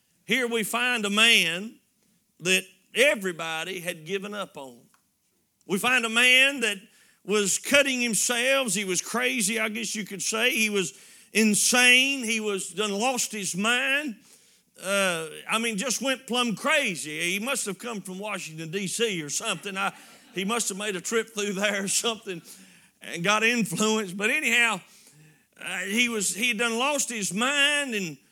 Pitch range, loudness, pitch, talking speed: 195-235 Hz, -24 LUFS, 215 Hz, 165 wpm